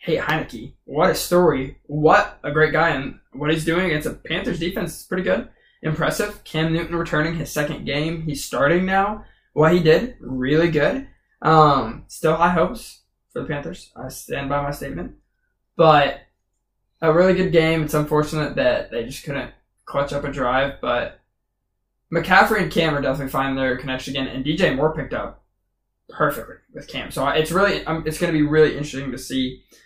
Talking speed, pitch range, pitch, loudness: 185 wpm, 140-165 Hz, 155 Hz, -20 LUFS